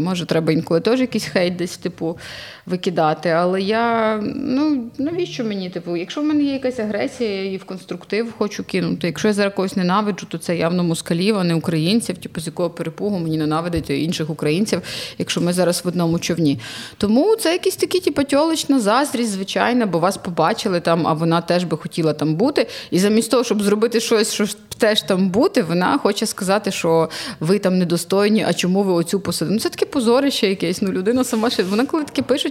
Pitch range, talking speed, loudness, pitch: 170-230 Hz, 195 wpm, -19 LUFS, 195 Hz